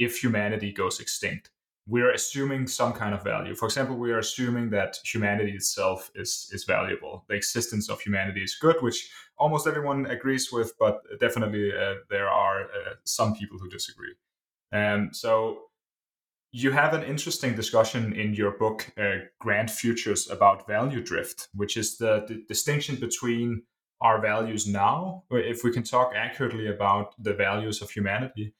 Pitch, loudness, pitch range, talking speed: 115 Hz, -27 LUFS, 105-130 Hz, 165 wpm